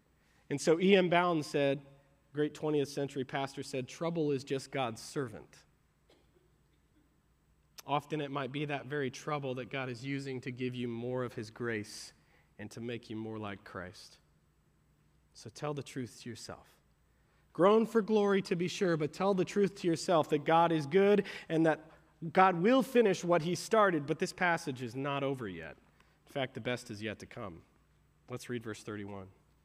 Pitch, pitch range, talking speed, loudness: 140 Hz, 120-165 Hz, 180 wpm, -33 LUFS